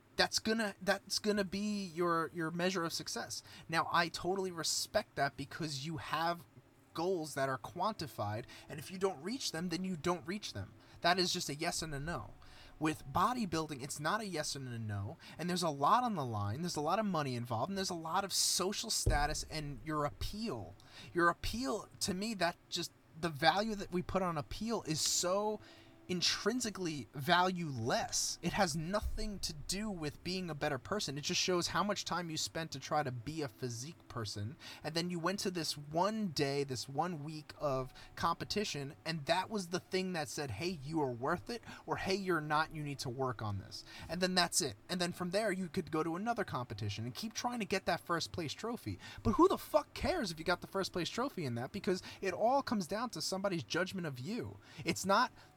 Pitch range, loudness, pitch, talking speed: 145-190 Hz, -37 LUFS, 170 Hz, 220 wpm